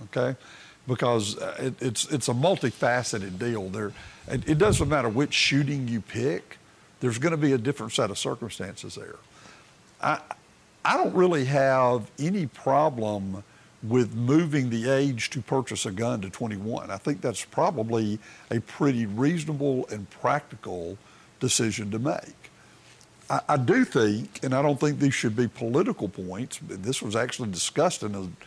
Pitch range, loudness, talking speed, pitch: 110-140 Hz, -26 LUFS, 160 wpm, 125 Hz